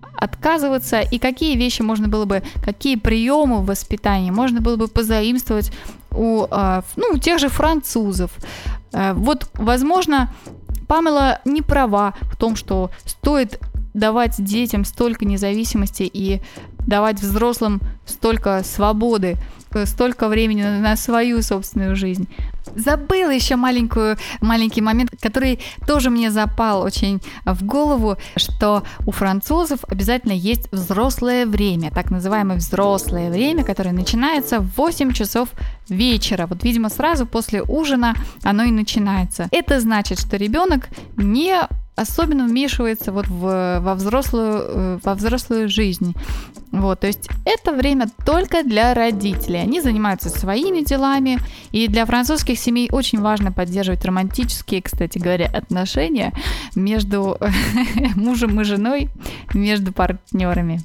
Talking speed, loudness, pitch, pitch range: 120 wpm, -19 LUFS, 220 Hz, 200-250 Hz